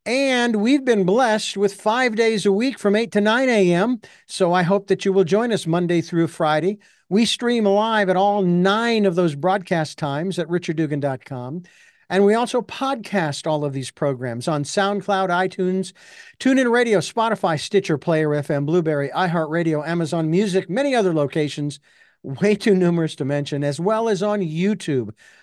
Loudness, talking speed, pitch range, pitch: -20 LUFS, 170 wpm, 160-210 Hz, 190 Hz